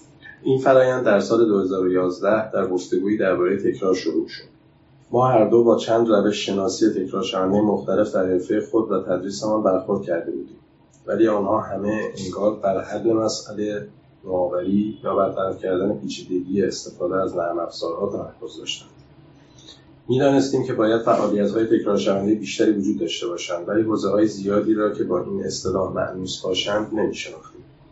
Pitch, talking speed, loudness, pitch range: 105 Hz, 150 wpm, -21 LUFS, 95-110 Hz